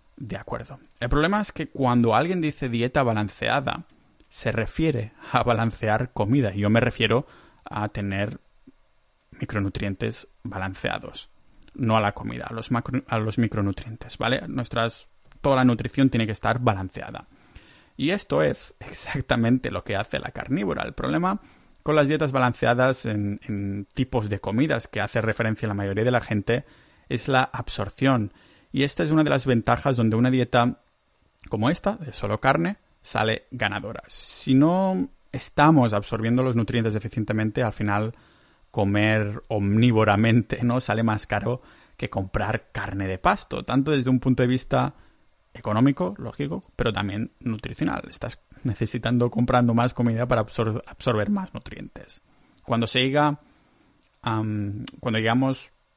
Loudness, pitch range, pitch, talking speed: -24 LUFS, 110-130 Hz, 120 Hz, 150 wpm